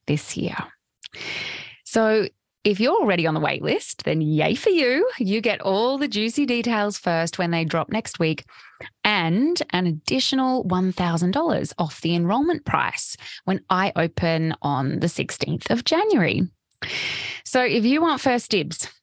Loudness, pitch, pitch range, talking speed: -22 LUFS, 190 Hz, 165-240 Hz, 150 wpm